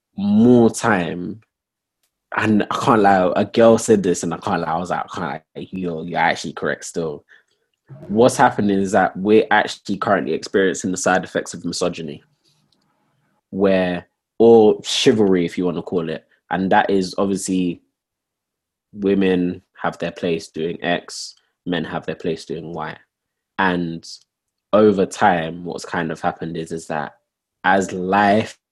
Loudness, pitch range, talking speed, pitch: -19 LUFS, 85-105 Hz, 155 wpm, 95 Hz